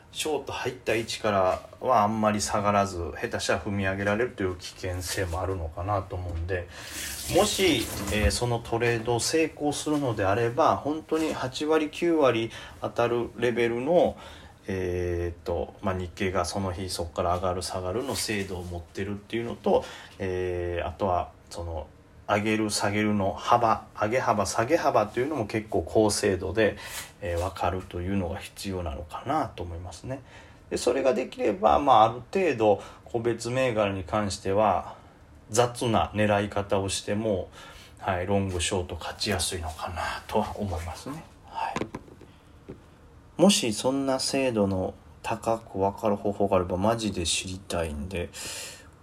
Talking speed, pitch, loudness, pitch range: 315 characters per minute, 100 Hz, -27 LUFS, 90-115 Hz